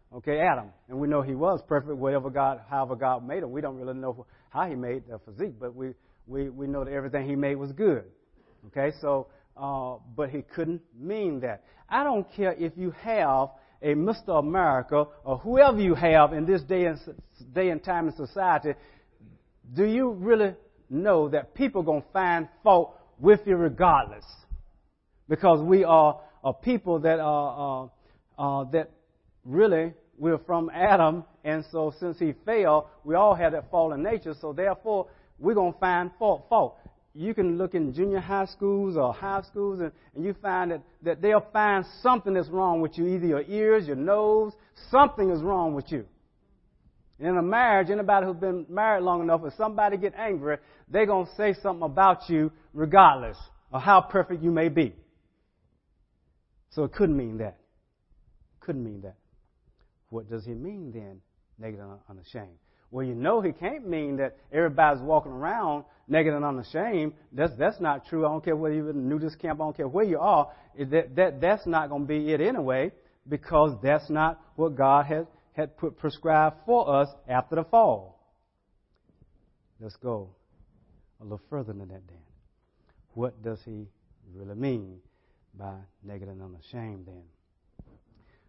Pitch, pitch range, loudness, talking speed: 155 Hz, 130-180 Hz, -26 LUFS, 175 wpm